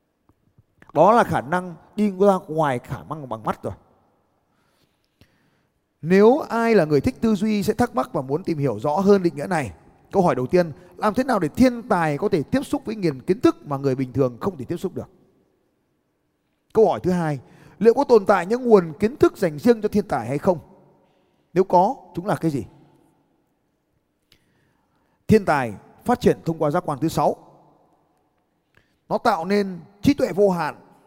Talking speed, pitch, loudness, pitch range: 195 wpm, 180 Hz, -21 LUFS, 150-210 Hz